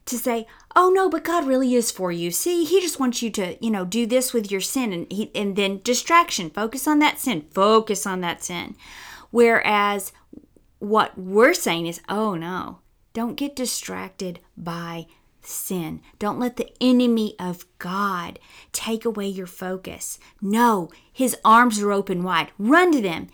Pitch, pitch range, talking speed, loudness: 215 Hz, 185-245 Hz, 170 wpm, -22 LUFS